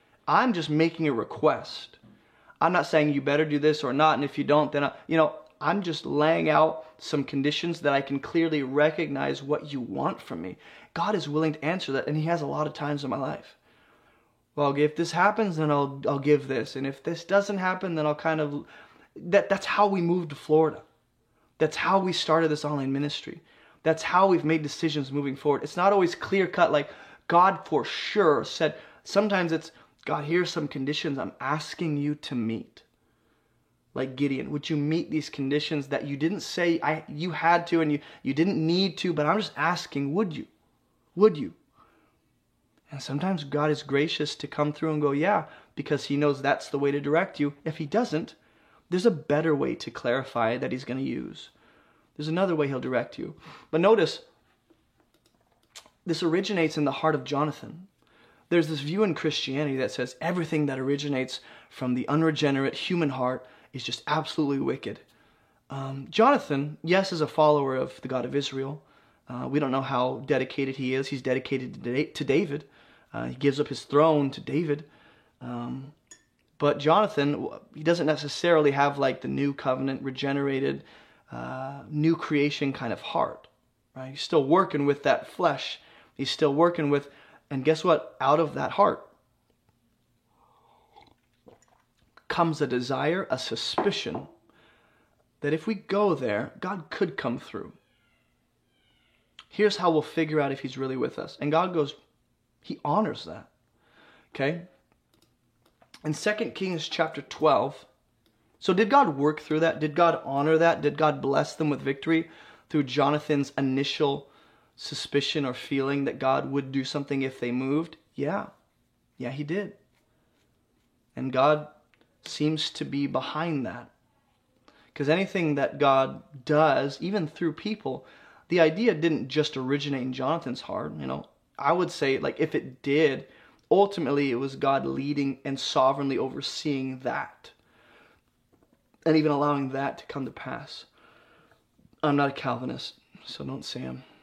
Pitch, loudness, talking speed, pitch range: 150 Hz, -27 LUFS, 170 wpm, 140-165 Hz